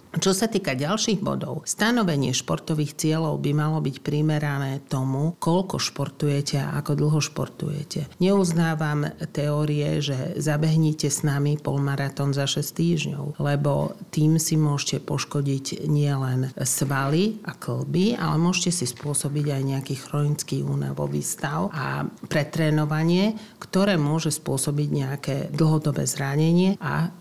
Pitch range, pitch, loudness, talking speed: 140-165 Hz, 150 Hz, -24 LUFS, 125 wpm